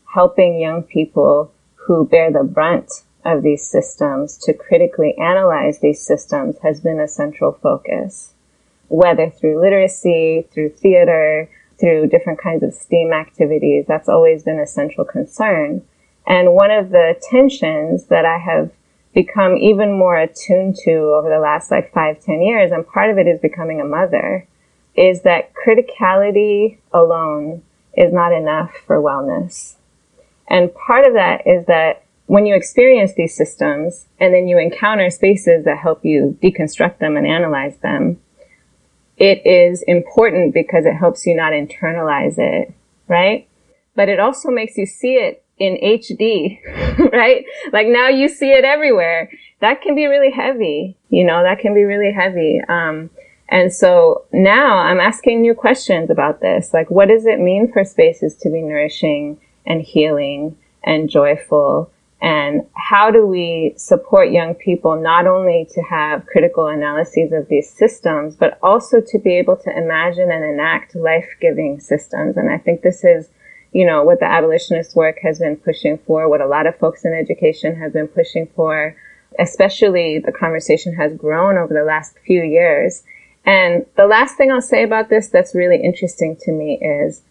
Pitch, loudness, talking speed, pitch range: 180 Hz, -14 LUFS, 165 wpm, 160-225 Hz